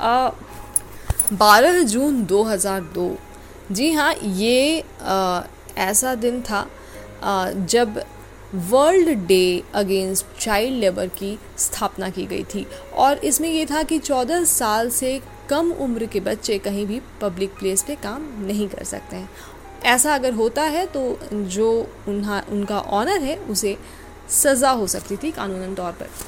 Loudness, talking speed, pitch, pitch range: -20 LUFS, 145 wpm, 210 Hz, 195-270 Hz